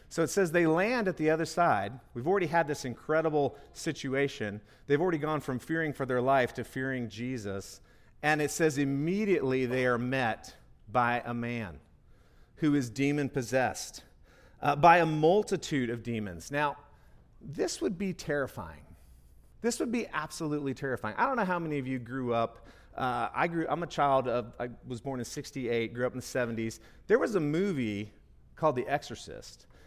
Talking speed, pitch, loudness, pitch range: 175 wpm, 135 Hz, -30 LUFS, 120-155 Hz